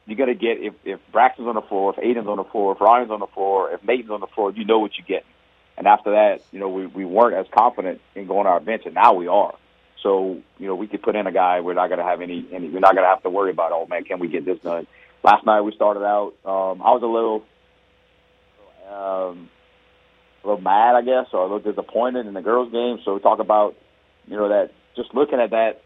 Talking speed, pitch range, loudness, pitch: 260 wpm, 95-115 Hz, -20 LUFS, 105 Hz